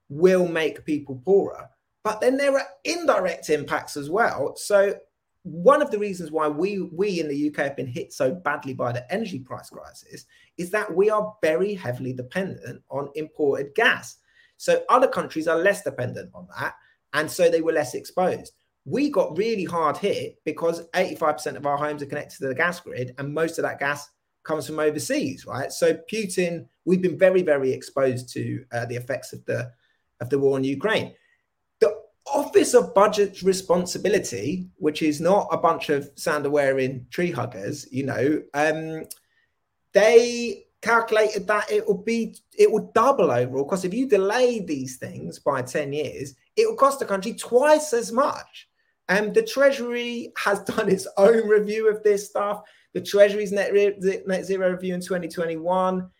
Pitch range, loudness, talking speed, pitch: 150-220 Hz, -23 LUFS, 180 wpm, 185 Hz